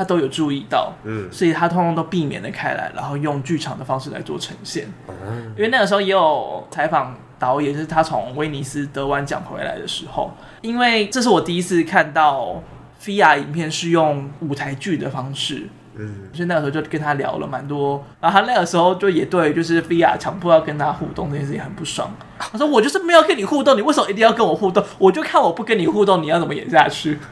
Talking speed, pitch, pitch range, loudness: 355 characters per minute, 160 Hz, 140-195 Hz, -18 LUFS